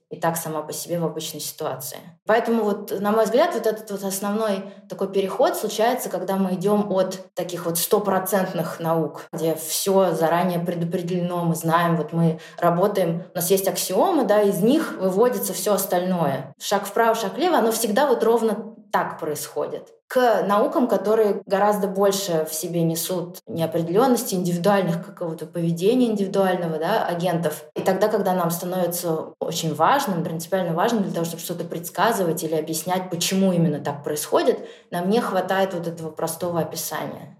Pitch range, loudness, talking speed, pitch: 165-205 Hz, -22 LUFS, 160 wpm, 185 Hz